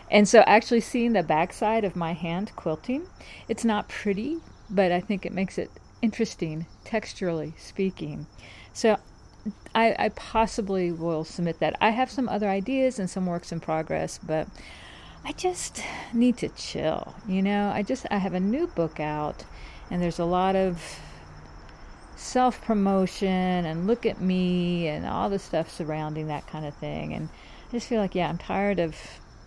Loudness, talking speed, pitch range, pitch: -26 LUFS, 170 wpm, 165-220 Hz, 190 Hz